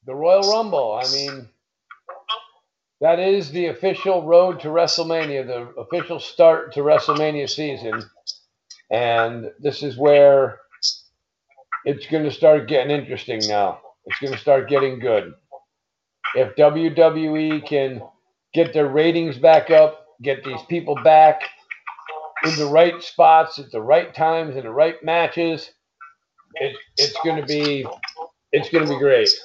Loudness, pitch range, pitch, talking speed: -18 LUFS, 140-165 Hz, 155 Hz, 140 wpm